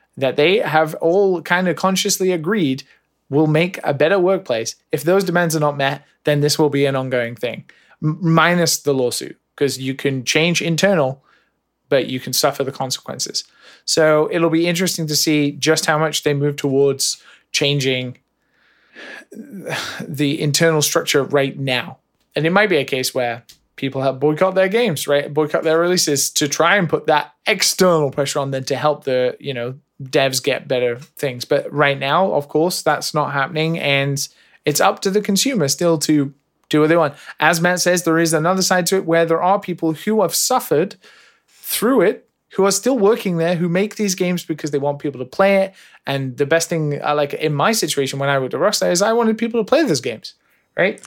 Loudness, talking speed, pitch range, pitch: -18 LUFS, 195 wpm, 140-180 Hz, 155 Hz